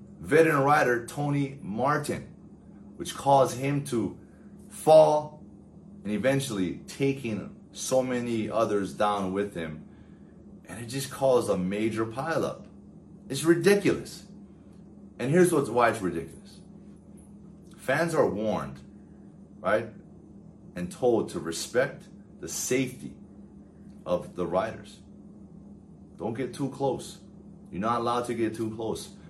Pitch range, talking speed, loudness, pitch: 110-145 Hz, 115 wpm, -27 LUFS, 125 Hz